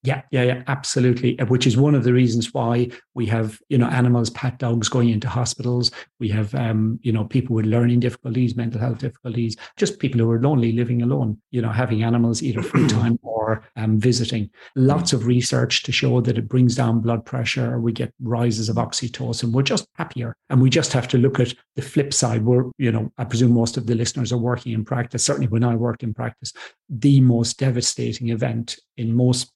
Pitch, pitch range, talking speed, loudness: 120 Hz, 115-130 Hz, 210 wpm, -21 LUFS